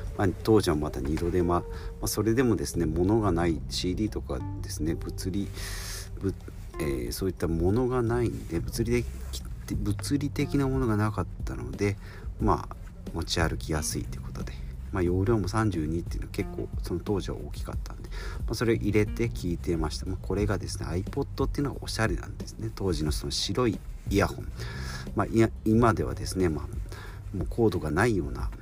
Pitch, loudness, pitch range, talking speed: 95 Hz, -29 LUFS, 85-110 Hz, 380 characters per minute